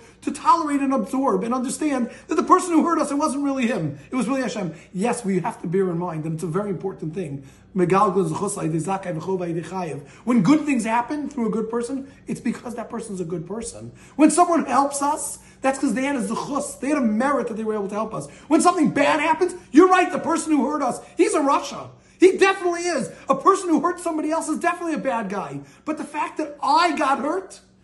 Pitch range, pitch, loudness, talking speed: 200-310 Hz, 265 Hz, -22 LUFS, 225 wpm